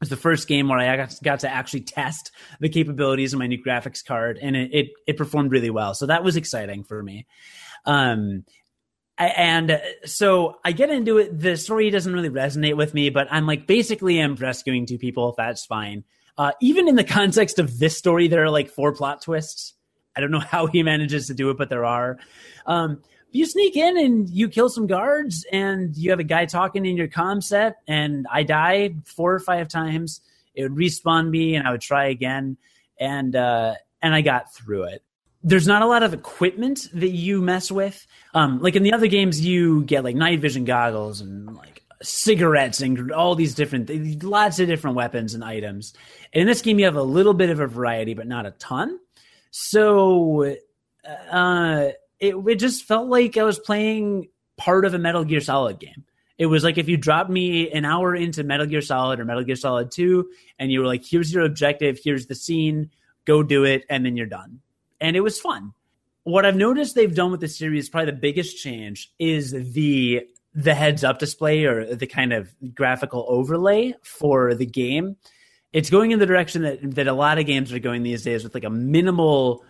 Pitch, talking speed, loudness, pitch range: 155 Hz, 210 wpm, -21 LUFS, 130-180 Hz